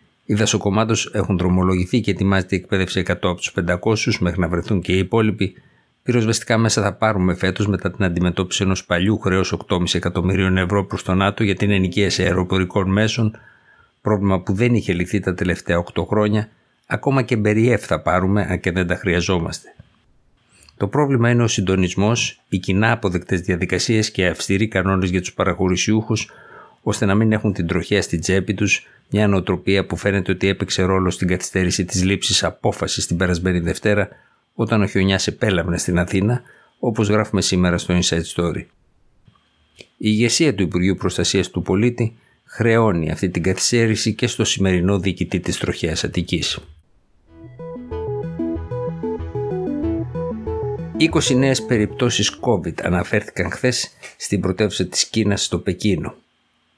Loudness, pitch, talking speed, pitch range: -19 LUFS, 100 Hz, 145 wpm, 90-110 Hz